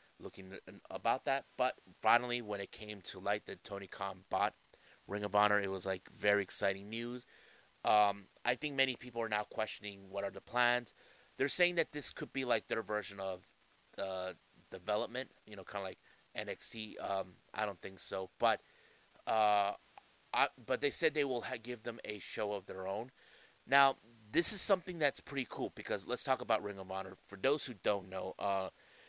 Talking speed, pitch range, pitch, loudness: 190 wpm, 100-125 Hz, 105 Hz, -37 LUFS